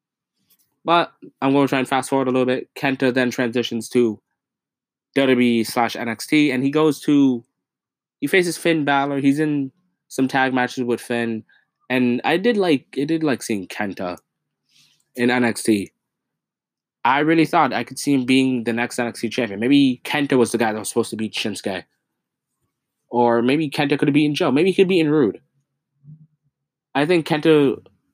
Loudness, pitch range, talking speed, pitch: -19 LUFS, 120-150 Hz, 175 wpm, 130 Hz